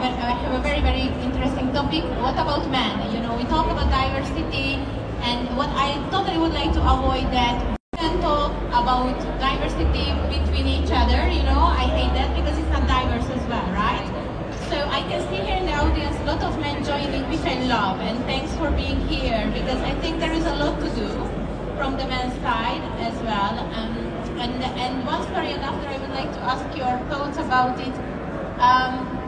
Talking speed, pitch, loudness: 195 wpm, 240 Hz, -23 LUFS